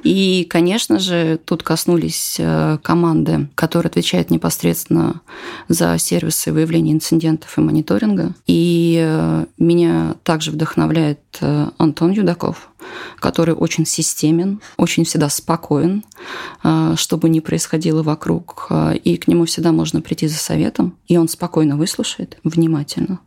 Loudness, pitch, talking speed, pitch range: -17 LUFS, 160 Hz, 115 wpm, 150-170 Hz